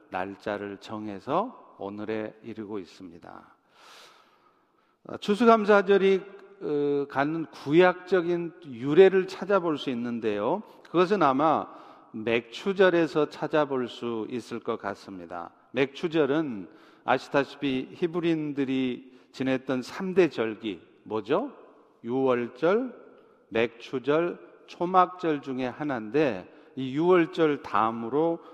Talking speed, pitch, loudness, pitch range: 225 characters per minute, 145 Hz, -27 LUFS, 120-180 Hz